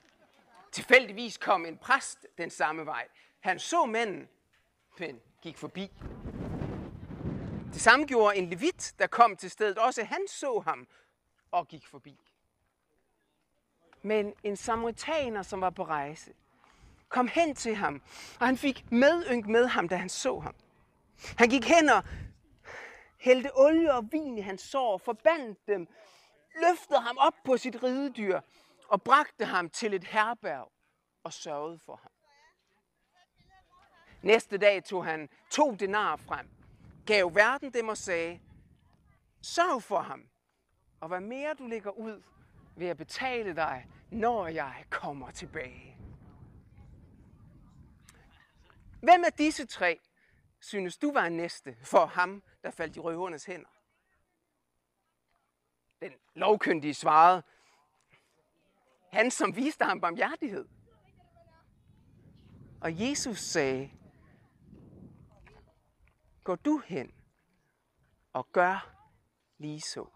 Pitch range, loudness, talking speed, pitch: 165-260 Hz, -29 LUFS, 120 wpm, 210 Hz